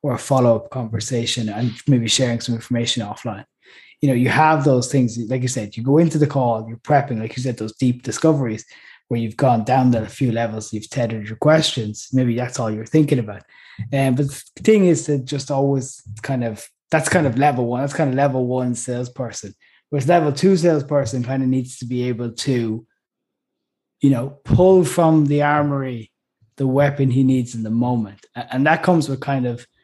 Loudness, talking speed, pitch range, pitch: -19 LUFS, 205 wpm, 115-145 Hz, 130 Hz